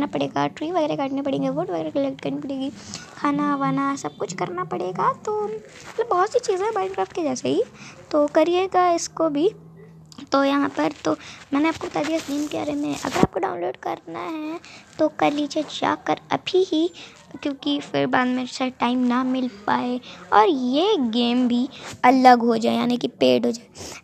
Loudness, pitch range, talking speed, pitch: -22 LUFS, 250-325 Hz, 185 wpm, 280 Hz